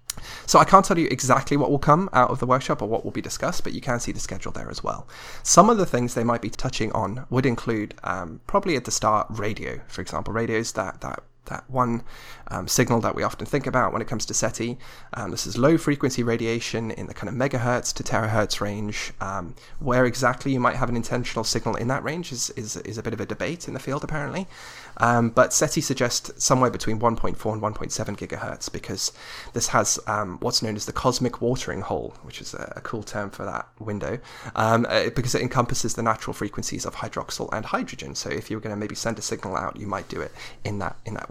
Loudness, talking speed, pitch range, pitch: -24 LUFS, 230 wpm, 110-130 Hz, 120 Hz